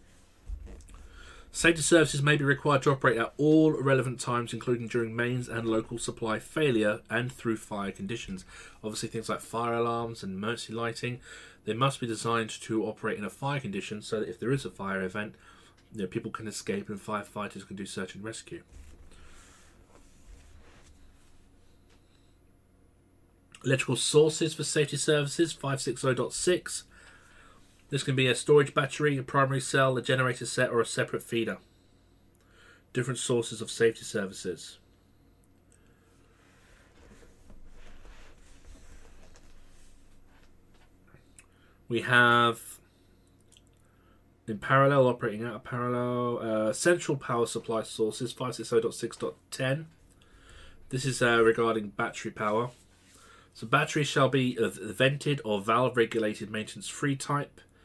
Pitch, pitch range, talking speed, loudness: 110 Hz, 95-130 Hz, 120 wpm, -29 LUFS